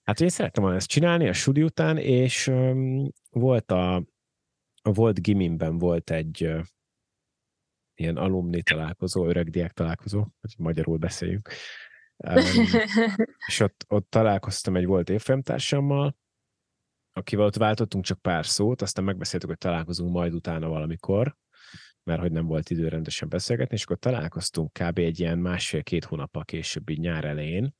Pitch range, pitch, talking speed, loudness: 85-130 Hz, 95 Hz, 145 wpm, -26 LUFS